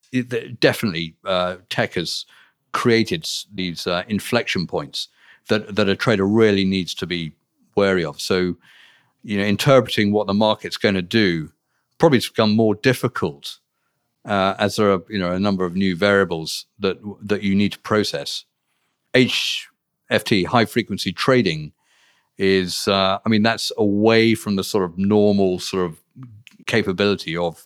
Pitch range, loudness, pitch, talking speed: 95-110 Hz, -20 LUFS, 100 Hz, 155 wpm